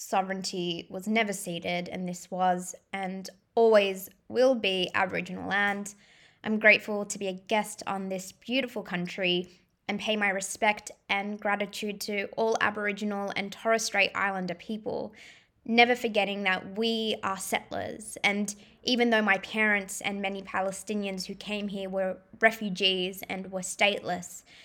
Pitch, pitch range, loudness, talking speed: 200 Hz, 190-215 Hz, -28 LUFS, 145 wpm